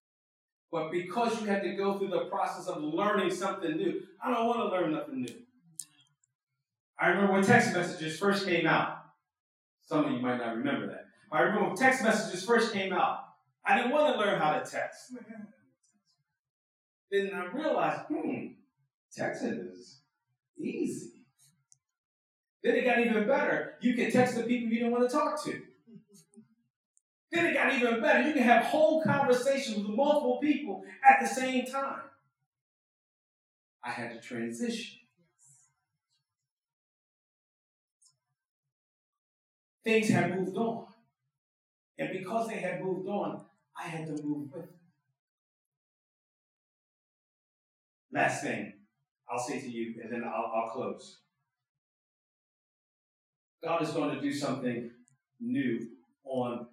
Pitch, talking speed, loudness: 185 Hz, 140 wpm, -30 LUFS